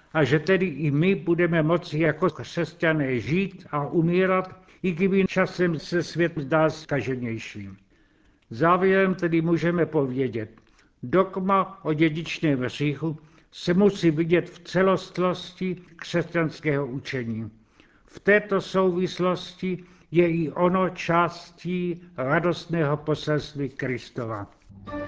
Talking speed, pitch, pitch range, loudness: 105 wpm, 165 Hz, 145-180 Hz, -24 LUFS